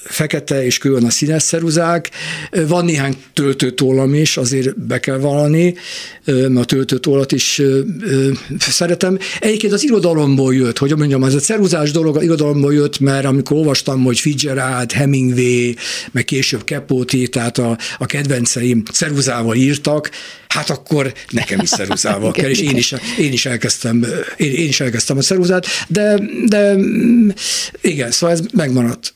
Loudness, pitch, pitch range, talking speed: -15 LUFS, 140 Hz, 130-170 Hz, 145 wpm